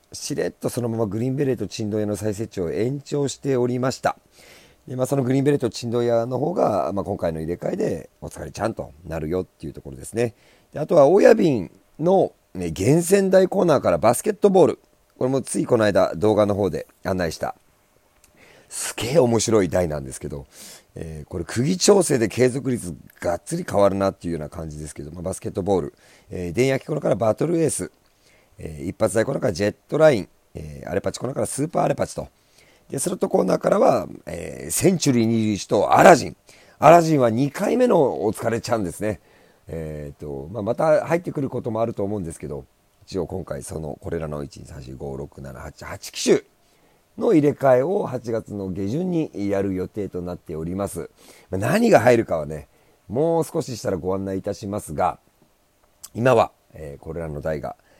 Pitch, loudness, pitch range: 105 Hz, -21 LUFS, 85-130 Hz